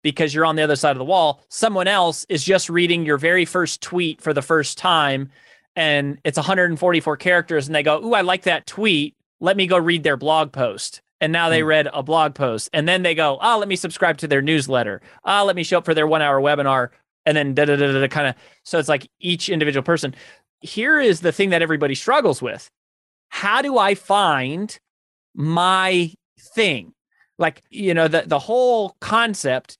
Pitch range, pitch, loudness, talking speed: 145-185 Hz, 160 Hz, -19 LUFS, 200 wpm